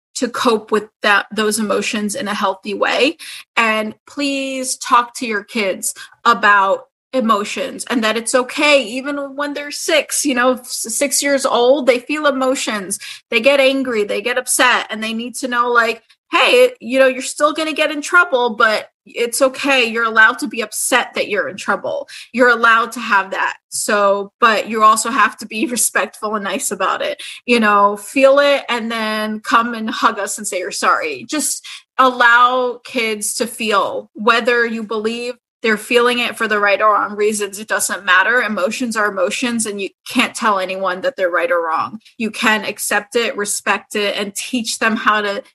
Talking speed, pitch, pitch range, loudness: 190 wpm, 235 Hz, 215-265 Hz, -16 LUFS